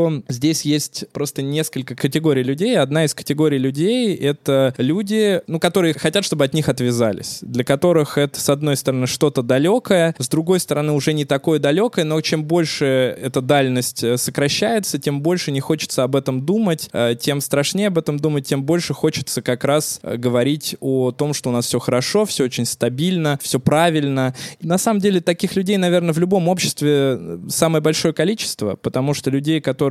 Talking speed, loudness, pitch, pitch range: 175 wpm, -18 LUFS, 150 Hz, 135-170 Hz